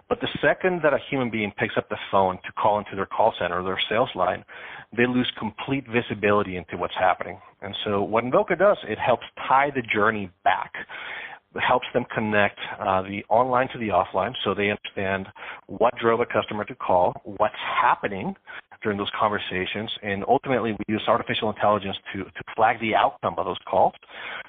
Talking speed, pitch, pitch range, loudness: 190 wpm, 105 Hz, 100-120 Hz, -24 LUFS